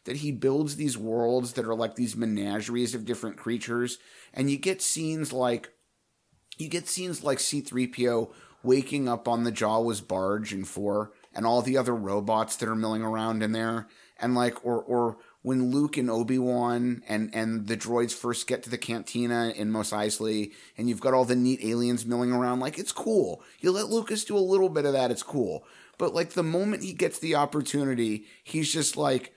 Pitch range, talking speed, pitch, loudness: 115-140 Hz, 195 wpm, 120 Hz, -28 LUFS